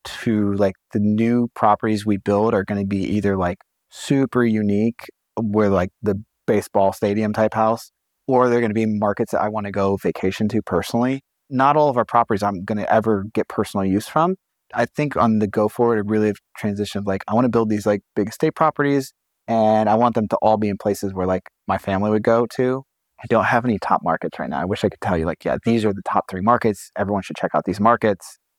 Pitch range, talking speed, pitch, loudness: 100-115 Hz, 225 wpm, 110 Hz, -20 LUFS